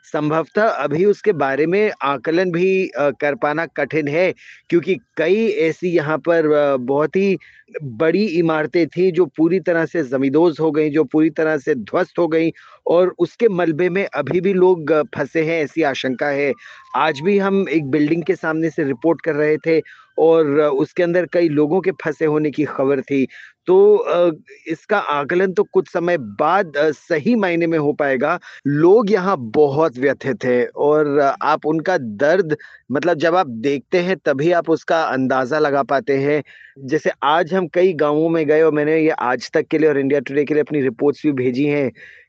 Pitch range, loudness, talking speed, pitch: 150-180 Hz, -18 LUFS, 180 wpm, 160 Hz